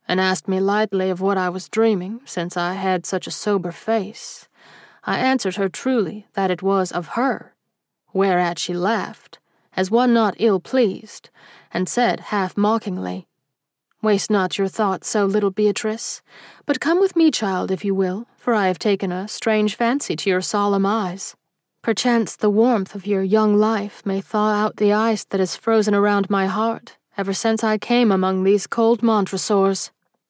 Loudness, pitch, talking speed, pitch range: -20 LUFS, 205 Hz, 175 wpm, 190-220 Hz